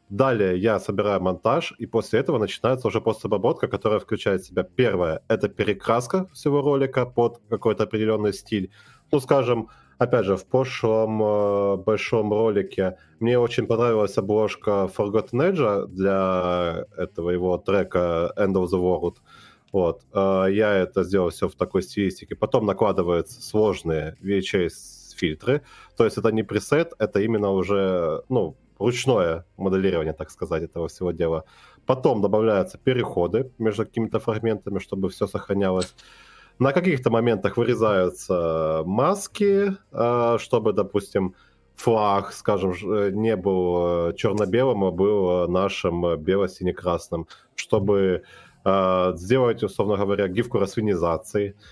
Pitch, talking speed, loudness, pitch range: 100 Hz, 125 wpm, -23 LUFS, 95-115 Hz